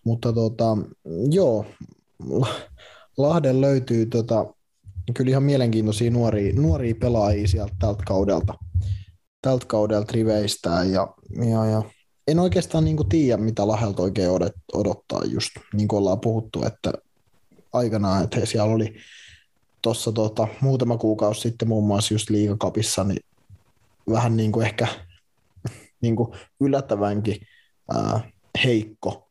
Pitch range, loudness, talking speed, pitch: 100-120 Hz, -23 LUFS, 115 wpm, 110 Hz